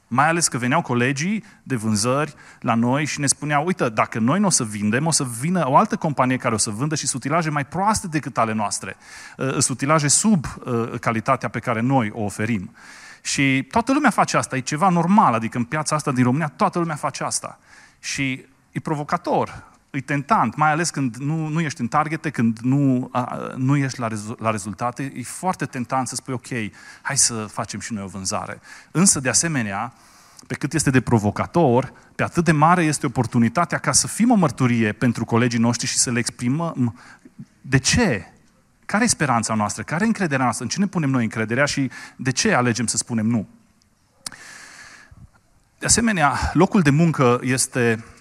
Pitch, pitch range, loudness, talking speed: 130 Hz, 120-155 Hz, -20 LUFS, 190 wpm